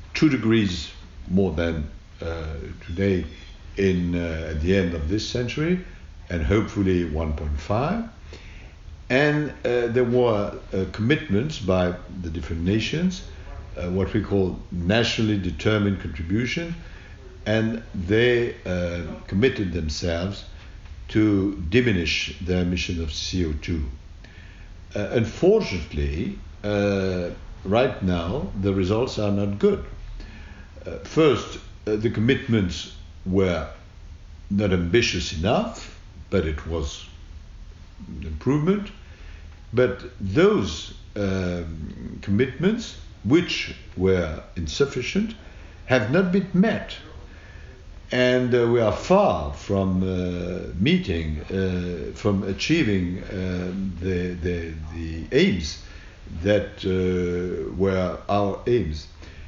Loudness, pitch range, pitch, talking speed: -24 LUFS, 85-105 Hz, 95 Hz, 100 wpm